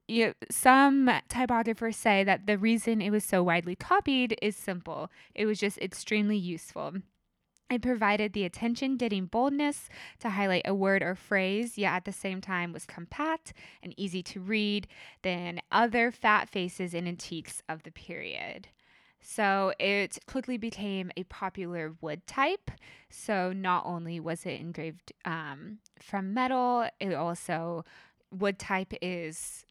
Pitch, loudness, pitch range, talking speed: 195 Hz, -30 LUFS, 180-225 Hz, 145 wpm